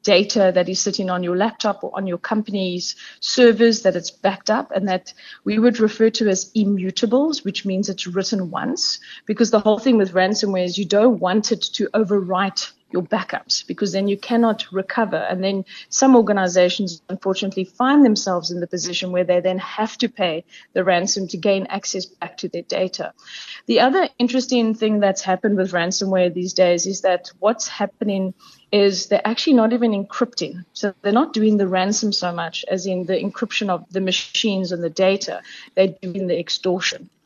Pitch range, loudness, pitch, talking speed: 185-215 Hz, -20 LUFS, 195 Hz, 185 wpm